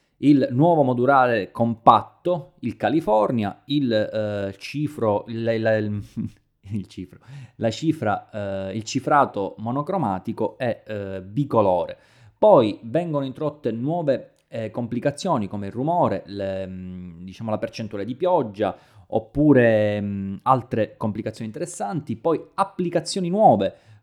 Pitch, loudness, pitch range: 115 Hz, -22 LUFS, 105-145 Hz